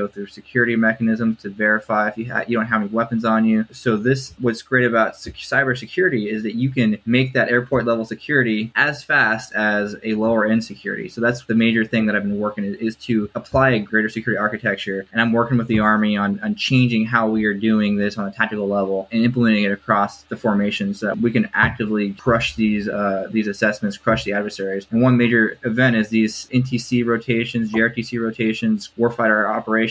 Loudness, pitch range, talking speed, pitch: -19 LUFS, 105-115 Hz, 205 wpm, 110 Hz